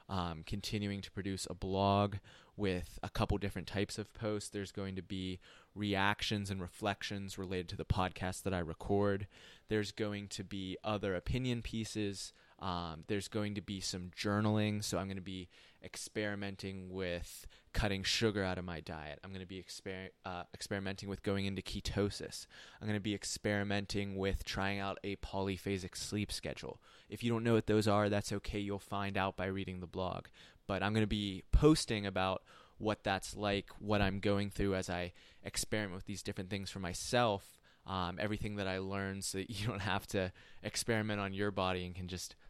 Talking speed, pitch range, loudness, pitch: 190 wpm, 95-105 Hz, -38 LUFS, 100 Hz